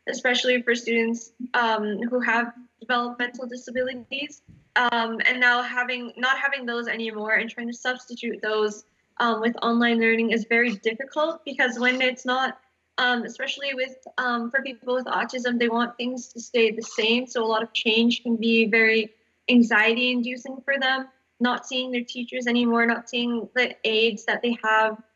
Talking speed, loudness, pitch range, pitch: 165 wpm, -23 LUFS, 230-255 Hz, 240 Hz